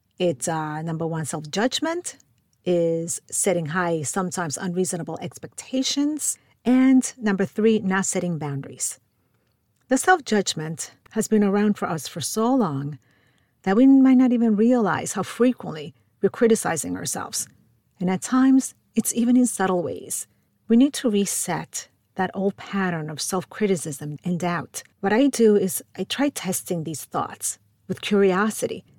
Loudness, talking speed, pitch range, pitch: -23 LUFS, 145 wpm, 160-225 Hz, 190 Hz